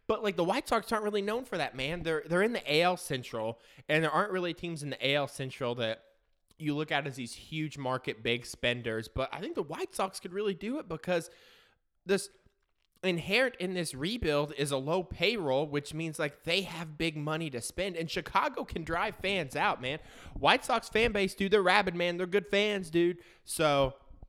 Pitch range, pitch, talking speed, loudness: 140-195 Hz, 165 Hz, 210 wpm, -31 LUFS